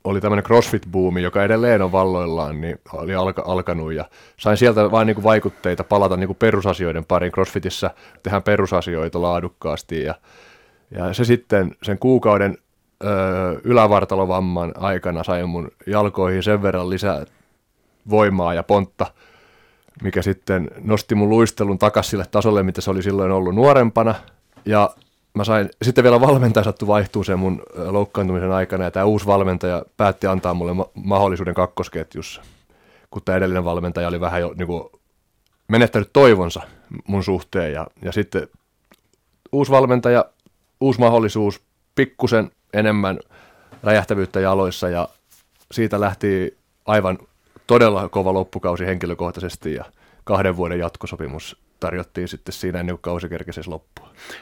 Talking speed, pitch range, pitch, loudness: 130 wpm, 90-105 Hz, 95 Hz, -19 LUFS